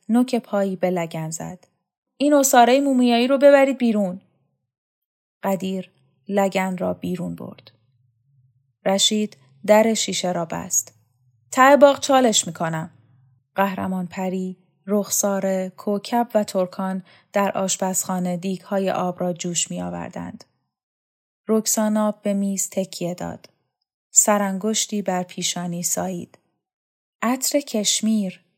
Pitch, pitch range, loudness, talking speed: 190 Hz, 170-215 Hz, -20 LUFS, 105 wpm